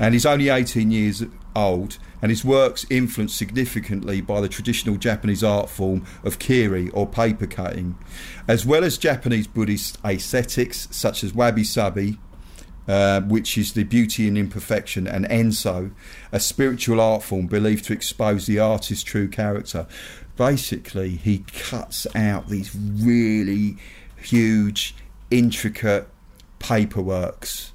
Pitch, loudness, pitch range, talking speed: 105 Hz, -22 LUFS, 100-115 Hz, 130 wpm